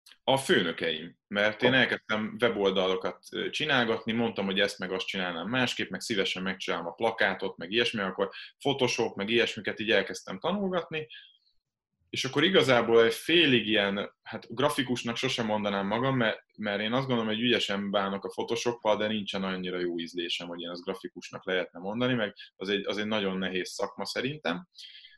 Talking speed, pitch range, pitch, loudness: 160 wpm, 100-120 Hz, 110 Hz, -28 LUFS